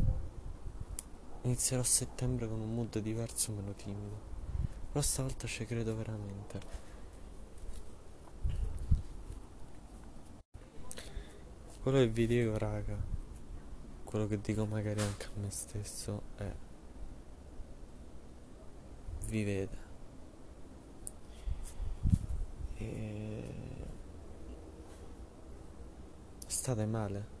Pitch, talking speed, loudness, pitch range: 90 Hz, 70 wpm, -37 LUFS, 75-105 Hz